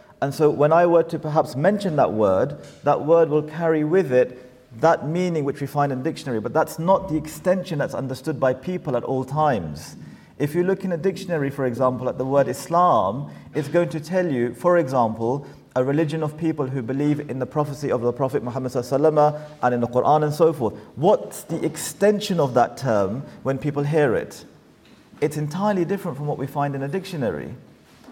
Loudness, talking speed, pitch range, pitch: -22 LUFS, 200 wpm, 135-165 Hz, 150 Hz